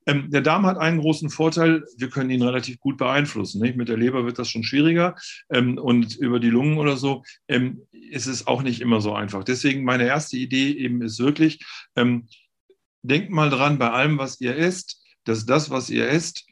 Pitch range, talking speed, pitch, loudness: 120-150 Hz, 205 wpm, 130 Hz, -22 LUFS